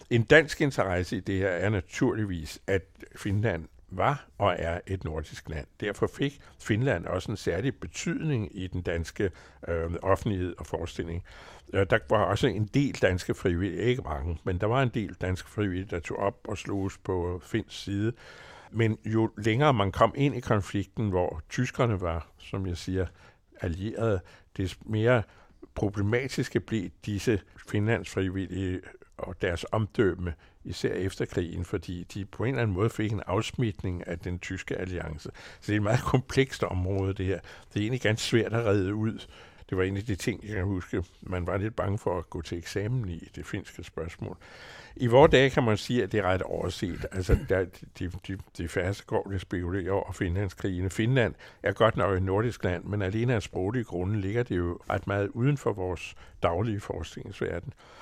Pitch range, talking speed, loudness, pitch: 90-110 Hz, 185 wpm, -29 LUFS, 100 Hz